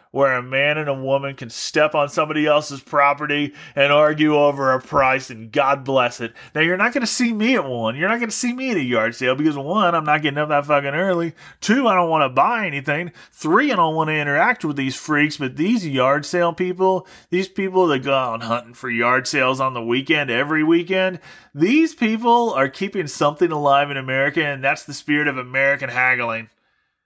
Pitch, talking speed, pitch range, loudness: 150 Hz, 220 wpm, 135-180 Hz, -19 LUFS